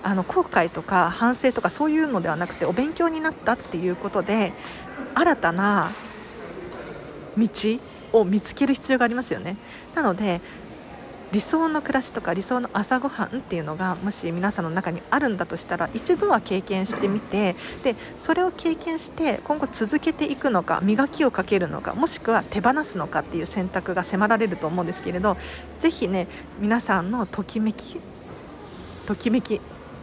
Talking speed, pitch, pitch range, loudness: 340 characters per minute, 215 Hz, 190-265 Hz, -24 LUFS